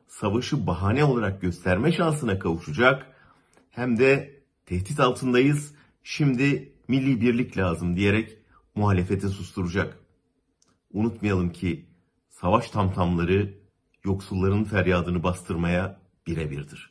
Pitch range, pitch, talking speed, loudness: 90-125 Hz, 100 Hz, 90 wpm, -25 LUFS